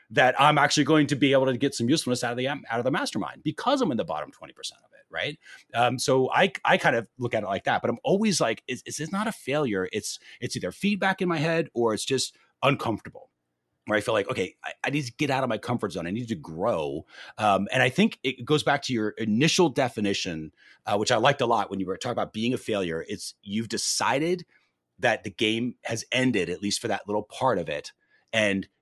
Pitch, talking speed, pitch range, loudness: 125 Hz, 250 wpm, 105-150 Hz, -26 LUFS